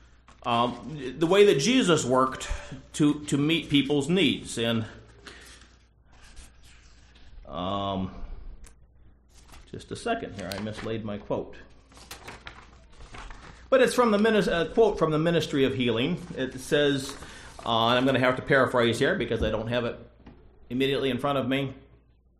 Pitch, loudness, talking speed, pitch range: 130 Hz, -25 LUFS, 140 wpm, 110-150 Hz